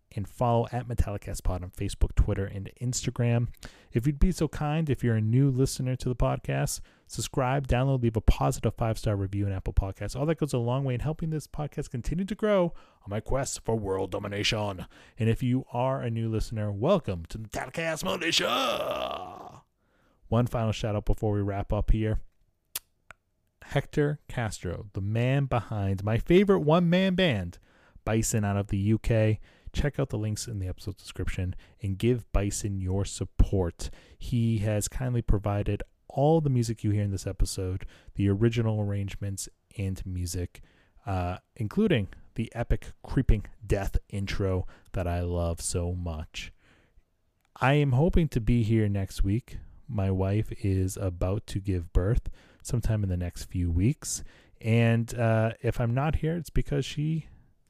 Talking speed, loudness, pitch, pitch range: 165 wpm, -29 LUFS, 110 Hz, 95-125 Hz